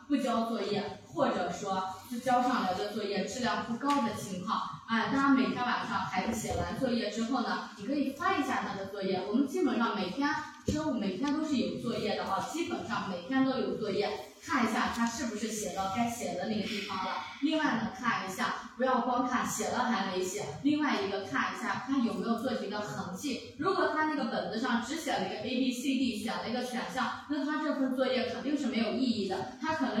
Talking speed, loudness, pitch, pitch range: 325 characters per minute, -32 LUFS, 240 Hz, 205-265 Hz